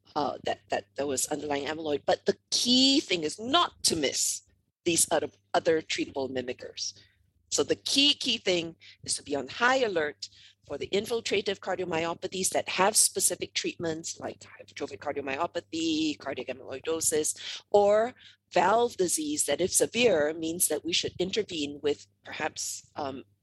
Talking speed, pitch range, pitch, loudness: 145 wpm, 135-205 Hz, 165 Hz, -28 LUFS